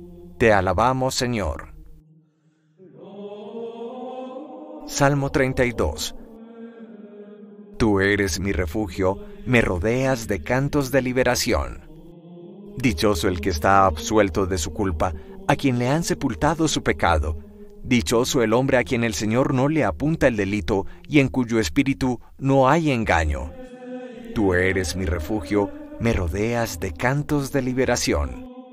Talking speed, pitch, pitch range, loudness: 125 wpm, 130 Hz, 100-160 Hz, -22 LUFS